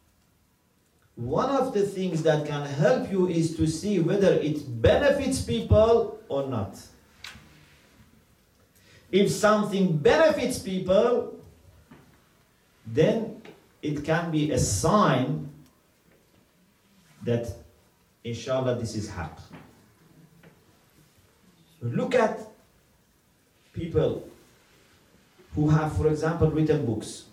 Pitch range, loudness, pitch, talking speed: 120-195 Hz, -25 LUFS, 155 Hz, 90 wpm